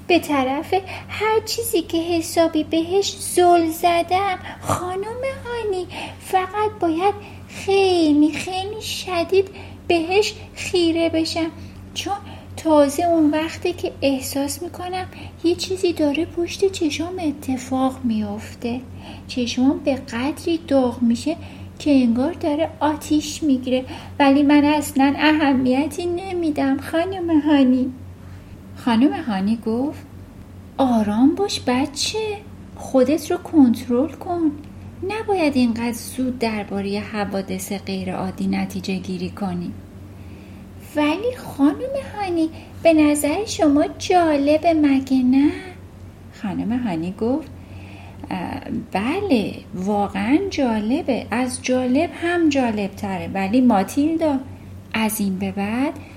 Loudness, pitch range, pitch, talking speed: -20 LUFS, 235-340 Hz, 290 Hz, 105 wpm